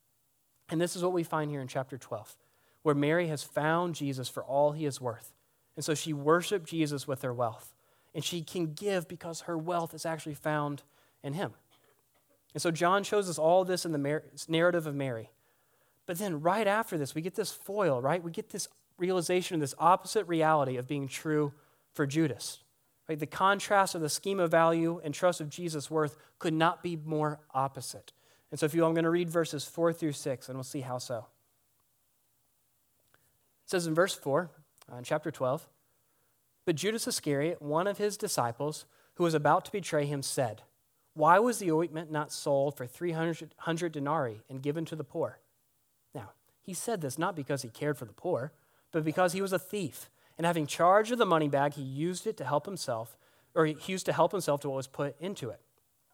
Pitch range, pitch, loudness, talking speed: 140-175 Hz, 155 Hz, -31 LUFS, 205 wpm